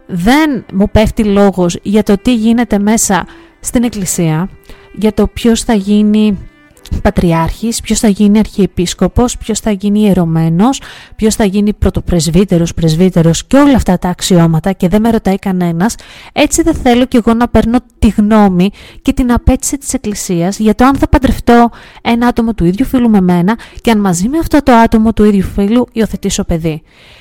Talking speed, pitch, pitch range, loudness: 170 wpm, 210 Hz, 185-235 Hz, -11 LUFS